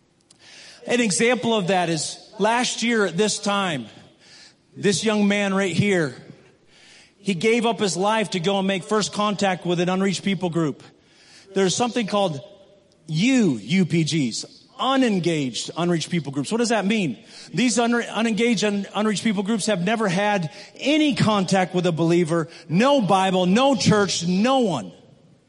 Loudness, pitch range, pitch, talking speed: -21 LUFS, 180-225 Hz, 200 Hz, 155 wpm